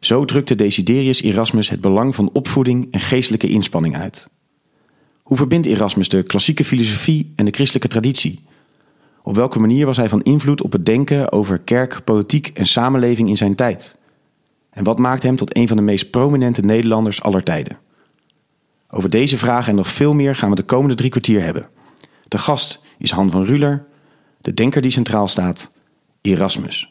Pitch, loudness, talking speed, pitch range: 125 Hz, -16 LUFS, 175 wpm, 105-140 Hz